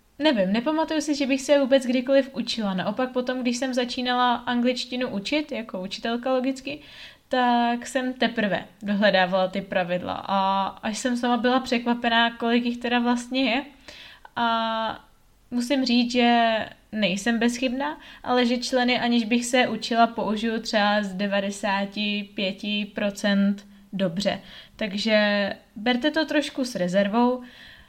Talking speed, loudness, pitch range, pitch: 130 wpm, -24 LUFS, 205-255 Hz, 235 Hz